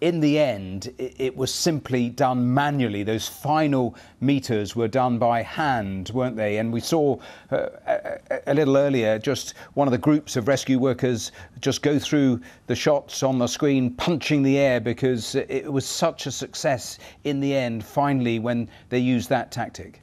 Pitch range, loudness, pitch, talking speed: 115-140 Hz, -23 LUFS, 130 Hz, 175 wpm